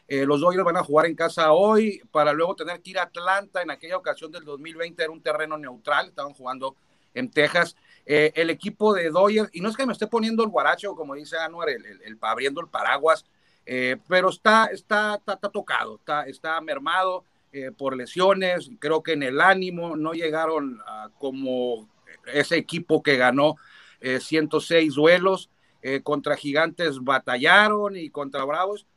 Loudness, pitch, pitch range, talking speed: -23 LUFS, 160 Hz, 145-185 Hz, 185 wpm